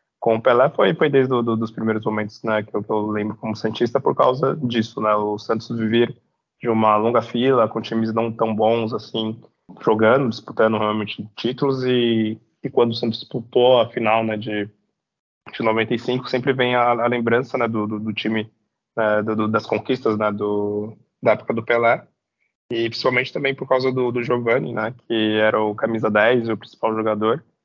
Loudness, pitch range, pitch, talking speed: -20 LUFS, 110-120 Hz, 115 Hz, 195 wpm